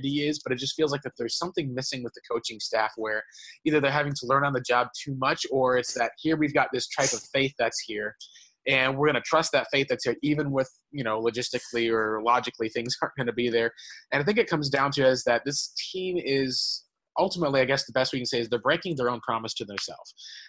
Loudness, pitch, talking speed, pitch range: -27 LUFS, 130 Hz, 250 wpm, 120-145 Hz